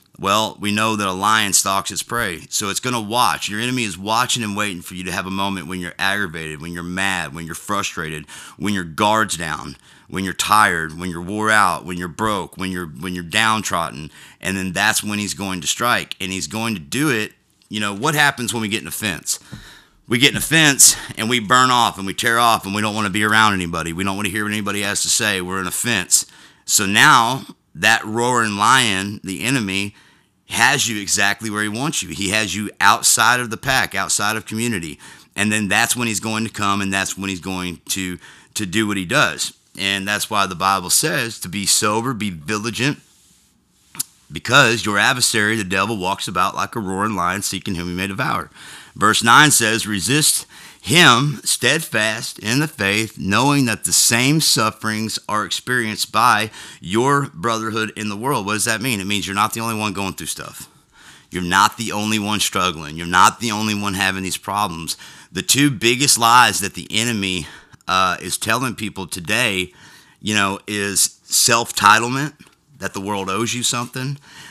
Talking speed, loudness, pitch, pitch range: 205 wpm, -17 LUFS, 105 Hz, 95-115 Hz